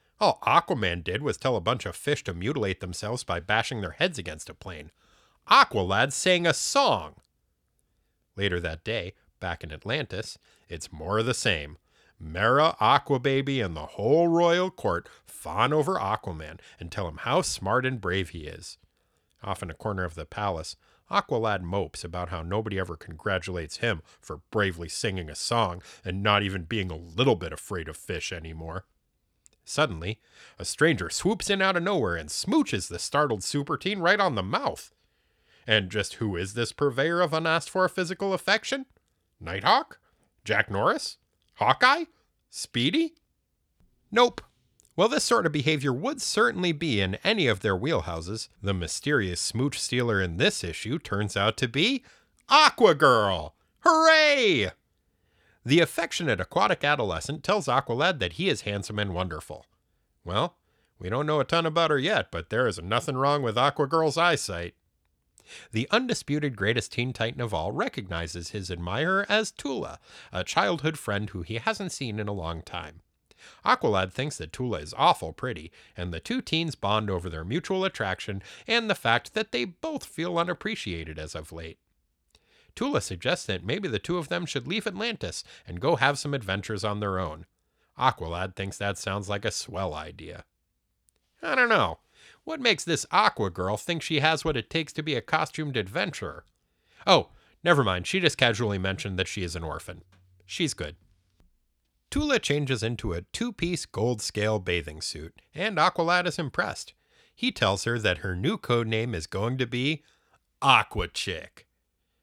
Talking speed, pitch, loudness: 165 wpm, 110 Hz, -26 LUFS